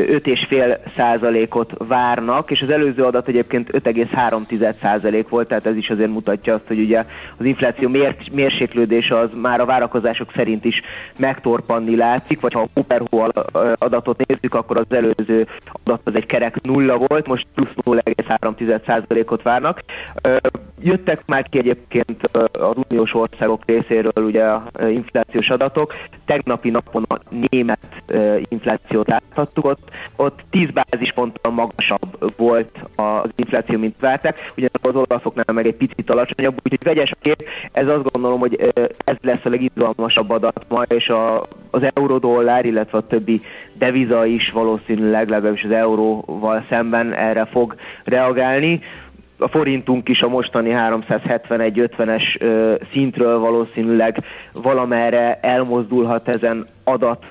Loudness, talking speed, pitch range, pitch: -18 LUFS, 135 wpm, 115-125 Hz, 120 Hz